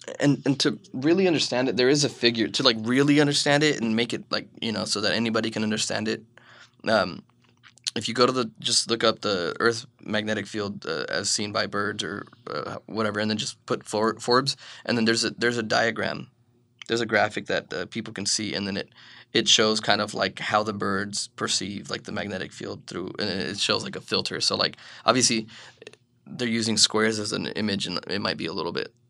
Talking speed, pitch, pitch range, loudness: 225 wpm, 115 Hz, 110-125 Hz, -25 LUFS